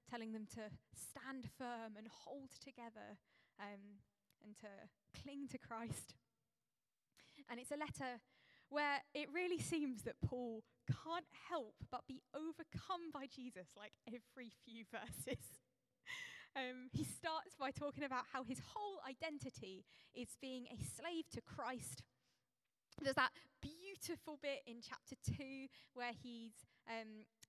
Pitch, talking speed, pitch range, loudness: 260 Hz, 135 wpm, 230-295 Hz, -49 LUFS